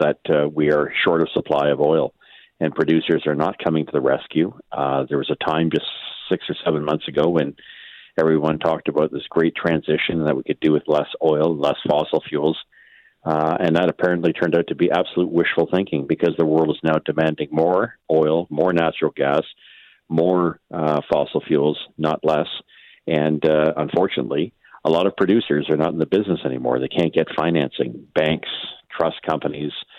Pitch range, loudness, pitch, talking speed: 75-80 Hz, -20 LUFS, 80 Hz, 185 wpm